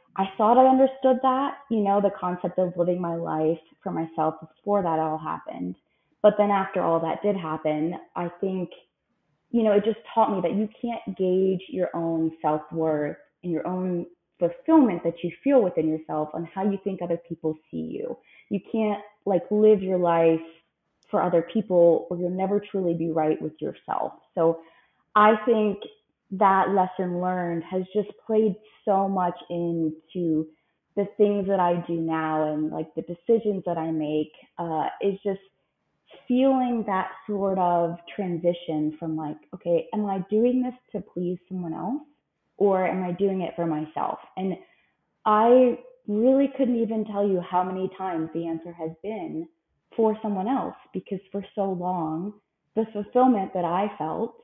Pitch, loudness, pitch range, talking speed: 185 Hz, -25 LUFS, 165-210 Hz, 170 wpm